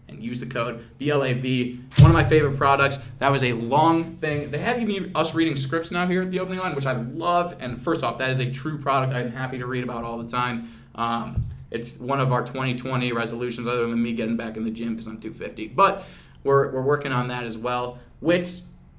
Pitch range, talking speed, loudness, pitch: 120-145 Hz, 230 wpm, -24 LUFS, 130 Hz